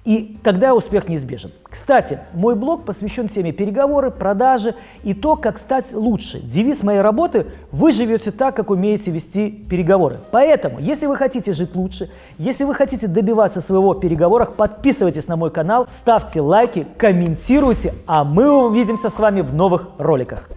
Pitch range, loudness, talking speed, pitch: 180-240 Hz, -17 LUFS, 160 wpm, 210 Hz